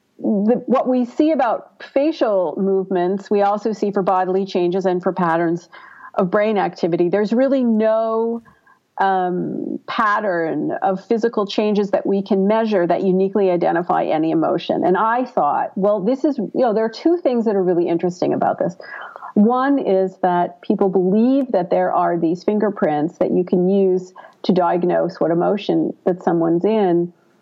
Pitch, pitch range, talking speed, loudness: 200 Hz, 180-225 Hz, 165 wpm, -18 LUFS